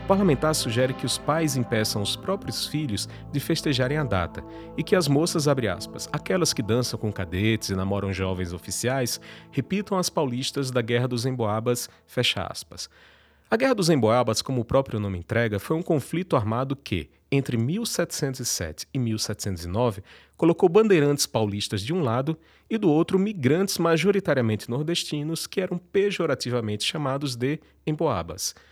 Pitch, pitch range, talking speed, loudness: 130 Hz, 110-160 Hz, 155 wpm, -25 LUFS